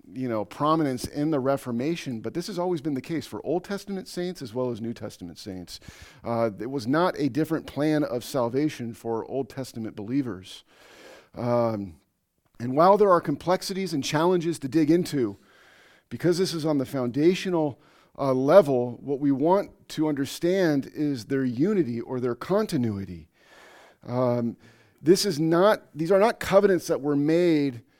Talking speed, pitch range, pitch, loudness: 165 wpm, 120-170 Hz, 140 Hz, -25 LUFS